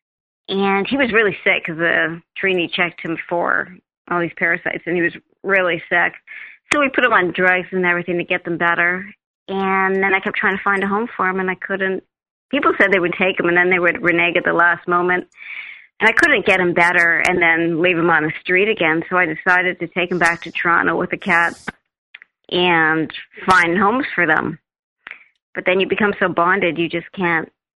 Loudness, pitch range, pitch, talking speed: -17 LUFS, 170-195 Hz, 180 Hz, 215 wpm